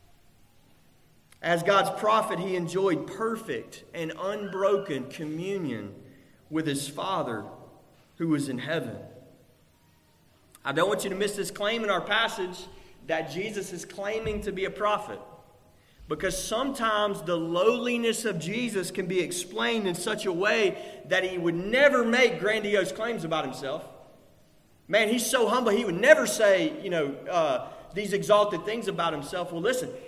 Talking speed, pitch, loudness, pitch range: 150 wpm, 195 Hz, -27 LUFS, 175-220 Hz